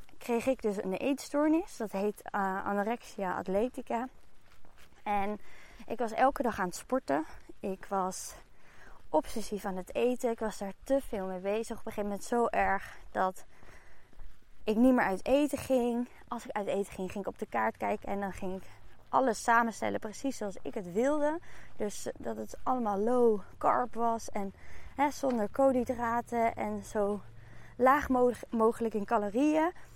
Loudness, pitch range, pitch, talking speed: -32 LUFS, 200-255 Hz, 225 Hz, 165 wpm